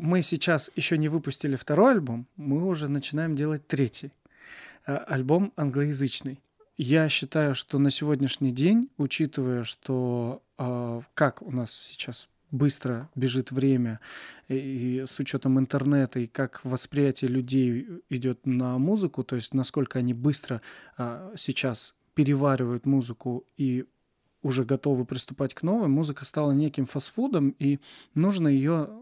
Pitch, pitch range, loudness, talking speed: 135 Hz, 130-150 Hz, -27 LUFS, 130 wpm